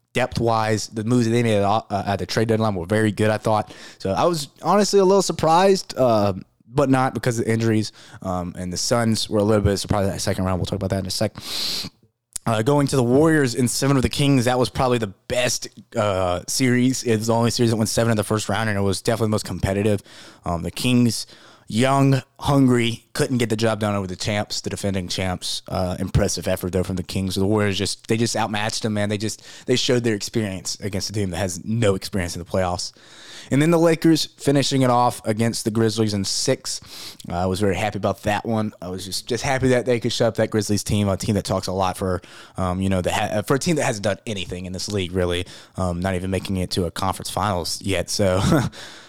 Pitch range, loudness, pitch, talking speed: 95-120 Hz, -21 LUFS, 110 Hz, 245 wpm